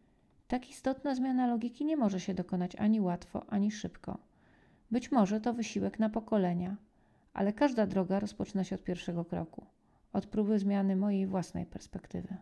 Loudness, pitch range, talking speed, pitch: -33 LUFS, 190-235 Hz, 155 wpm, 205 Hz